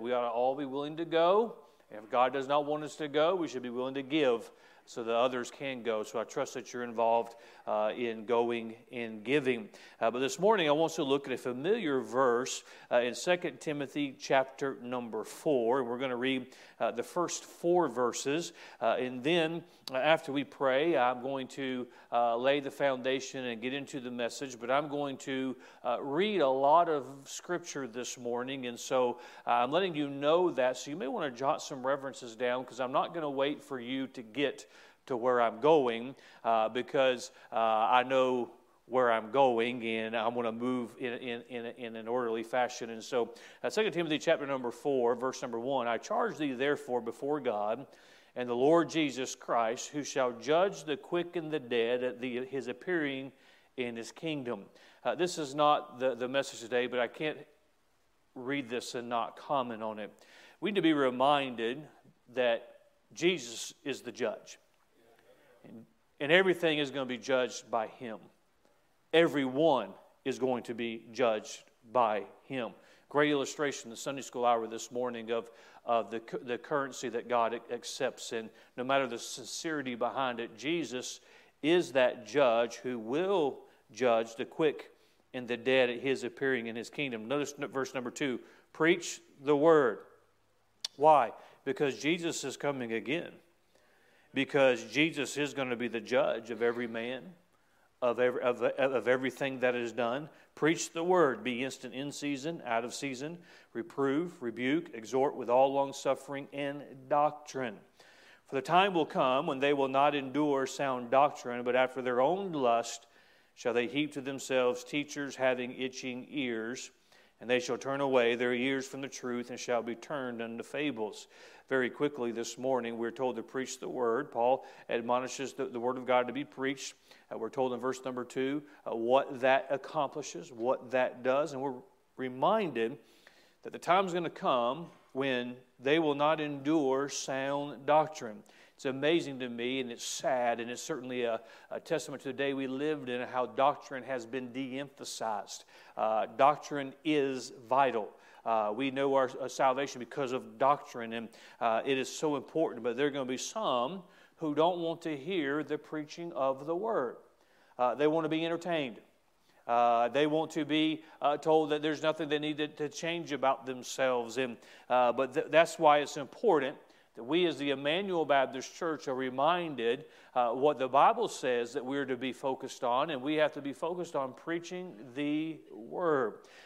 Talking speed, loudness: 180 wpm, -32 LUFS